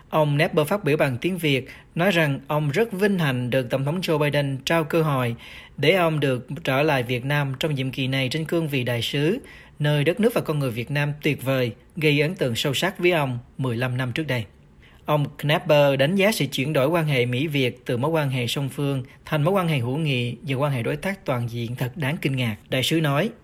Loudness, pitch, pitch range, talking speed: -23 LUFS, 145 Hz, 130-160 Hz, 240 wpm